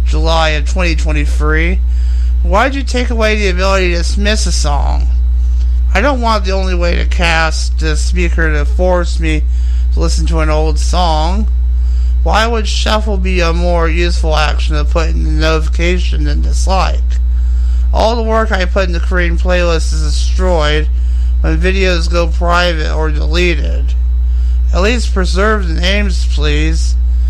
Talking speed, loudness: 150 wpm, -13 LUFS